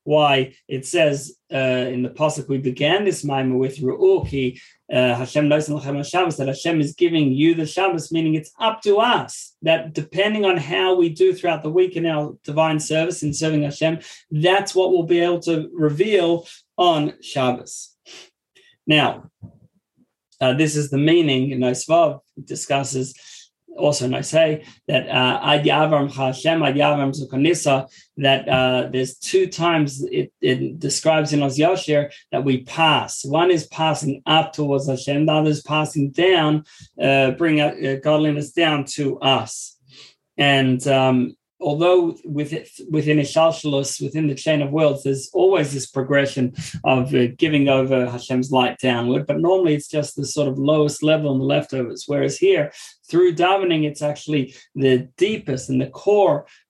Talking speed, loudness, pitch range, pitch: 150 wpm, -19 LUFS, 135-165 Hz, 150 Hz